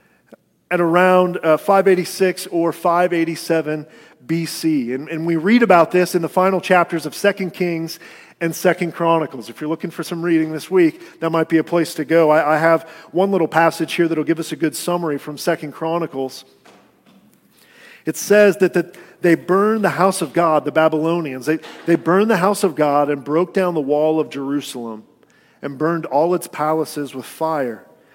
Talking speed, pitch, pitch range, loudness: 185 wpm, 165 Hz, 155-180 Hz, -18 LUFS